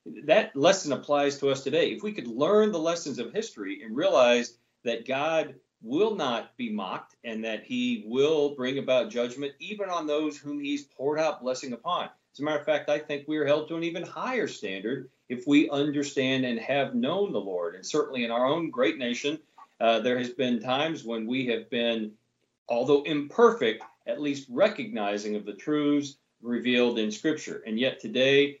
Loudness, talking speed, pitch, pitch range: -27 LUFS, 190 wpm, 145 Hz, 125-165 Hz